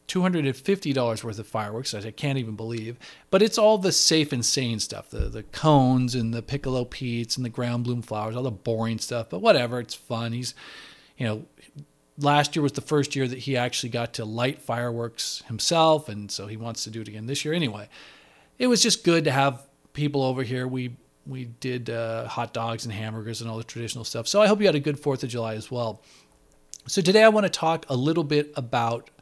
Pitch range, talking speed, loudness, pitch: 115-145 Hz, 220 wpm, -25 LUFS, 125 Hz